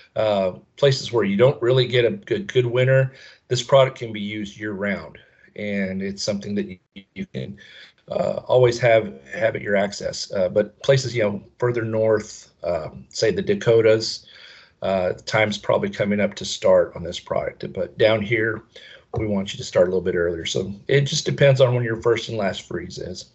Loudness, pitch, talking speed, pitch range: -21 LUFS, 110 Hz, 200 wpm, 100-125 Hz